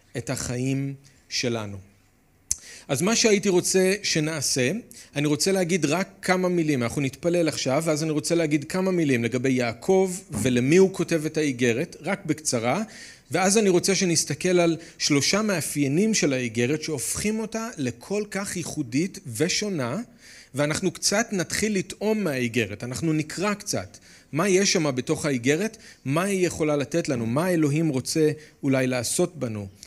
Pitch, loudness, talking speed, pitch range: 155 Hz, -24 LUFS, 145 wpm, 130-185 Hz